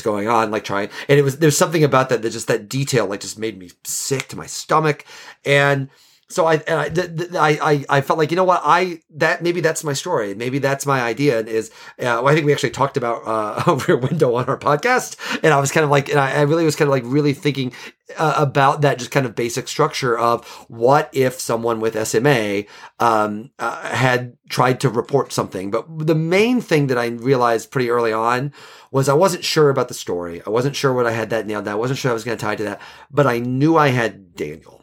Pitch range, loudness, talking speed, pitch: 115-150 Hz, -18 LUFS, 245 wpm, 135 Hz